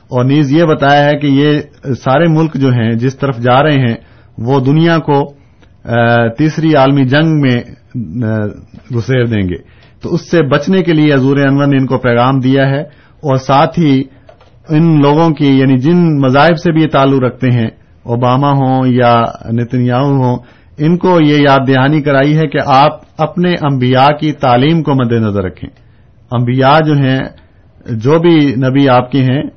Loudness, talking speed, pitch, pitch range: -10 LUFS, 175 wpm, 135 Hz, 120-150 Hz